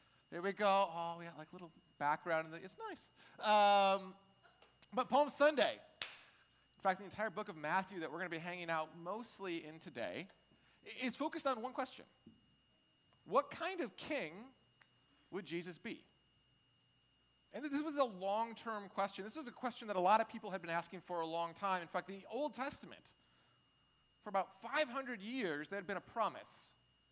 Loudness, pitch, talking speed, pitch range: -40 LUFS, 195 Hz, 190 wpm, 175-235 Hz